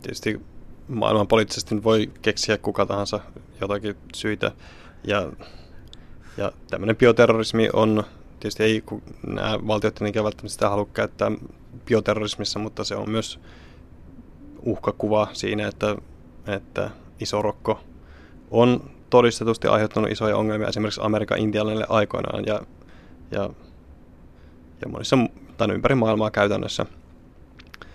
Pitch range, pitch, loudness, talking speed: 85-110 Hz, 105 Hz, -23 LUFS, 105 wpm